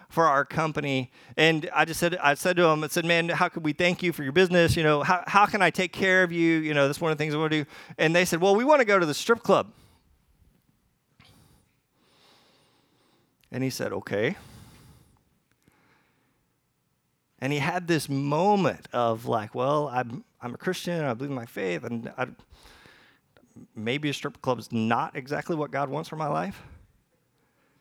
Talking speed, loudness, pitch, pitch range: 195 wpm, -25 LUFS, 155 Hz, 140-175 Hz